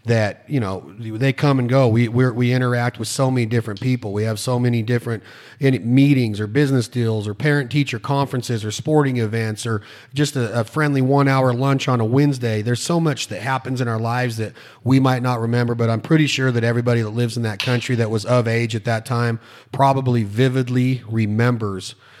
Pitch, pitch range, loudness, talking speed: 120 Hz, 115-130 Hz, -19 LUFS, 205 wpm